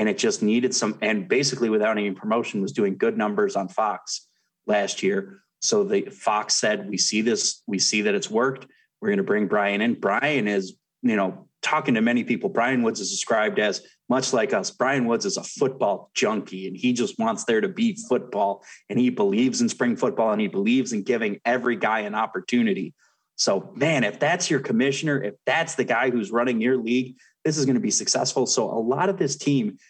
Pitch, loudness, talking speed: 130 Hz, -23 LUFS, 215 wpm